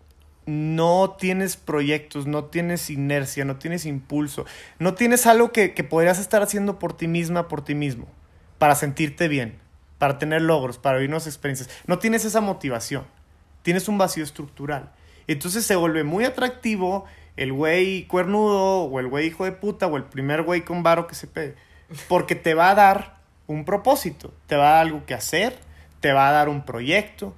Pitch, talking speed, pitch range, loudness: 160 Hz, 185 wpm, 140-185 Hz, -22 LUFS